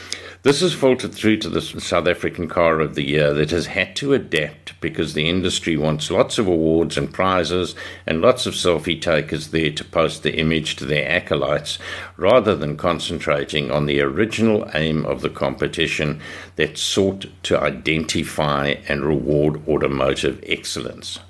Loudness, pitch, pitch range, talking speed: -20 LUFS, 80 Hz, 75-90 Hz, 160 wpm